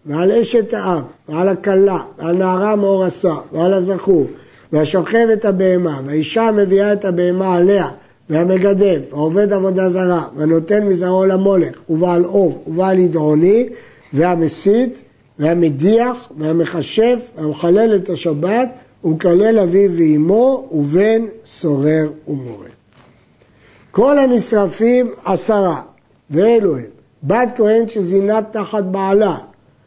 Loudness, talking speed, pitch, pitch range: -15 LUFS, 100 wpm, 185 Hz, 160-210 Hz